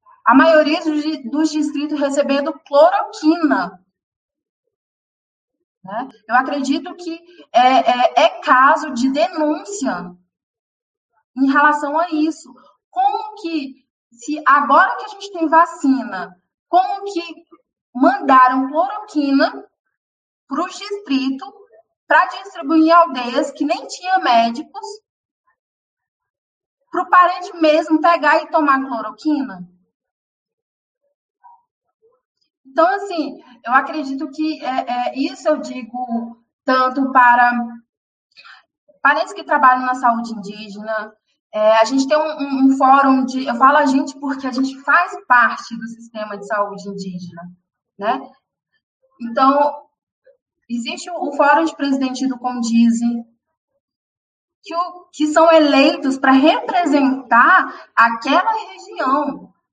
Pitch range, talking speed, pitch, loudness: 255-335 Hz, 110 wpm, 290 Hz, -16 LUFS